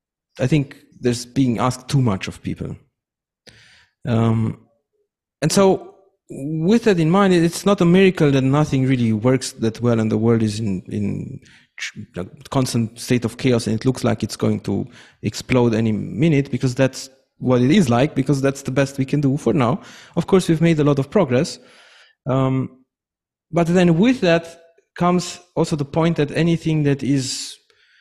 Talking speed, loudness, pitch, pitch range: 180 wpm, -19 LUFS, 135 Hz, 120-165 Hz